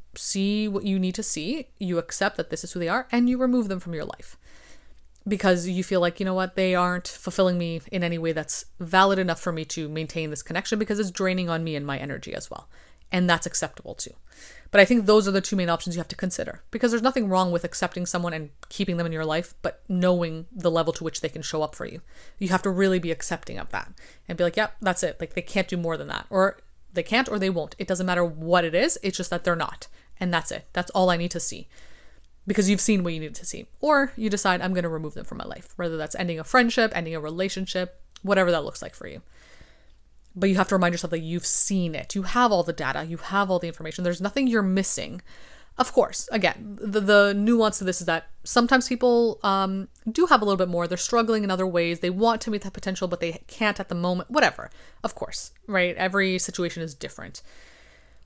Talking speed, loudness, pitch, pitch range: 250 wpm, -24 LUFS, 185 Hz, 170-200 Hz